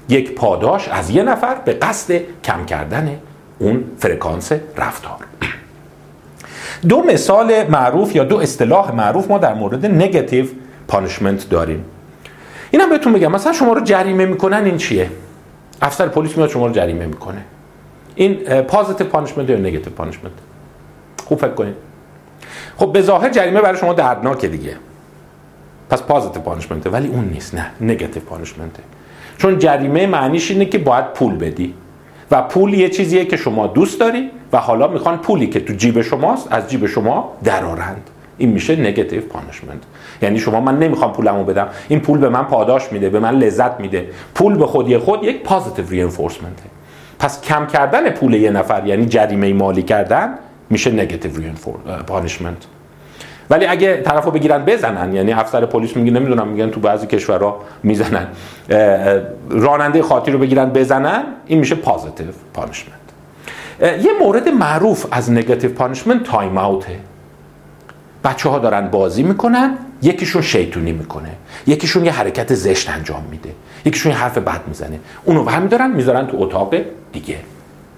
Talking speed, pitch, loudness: 150 wpm, 125 Hz, -15 LUFS